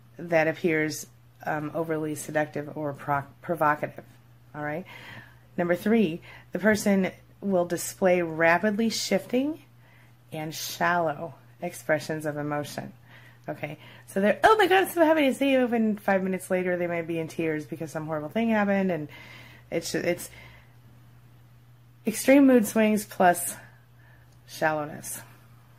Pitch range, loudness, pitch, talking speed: 120-185 Hz, -26 LUFS, 155 Hz, 135 wpm